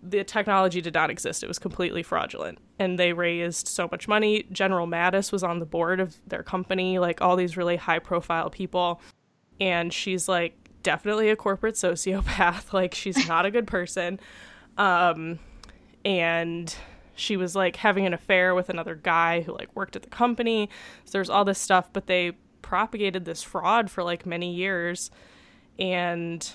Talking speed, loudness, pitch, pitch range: 170 wpm, -25 LUFS, 180 Hz, 170-195 Hz